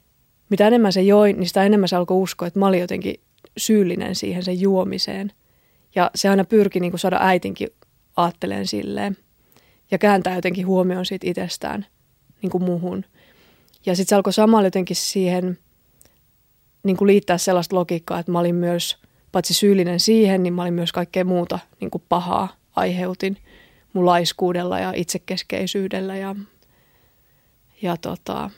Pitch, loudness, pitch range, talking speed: 185 Hz, -20 LUFS, 175-195 Hz, 155 wpm